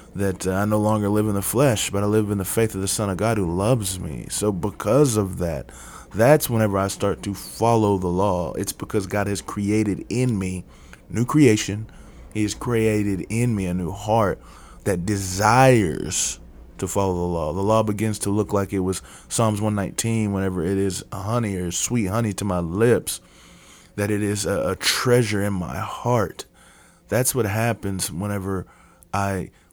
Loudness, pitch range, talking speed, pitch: -22 LUFS, 95-110 Hz, 180 wpm, 100 Hz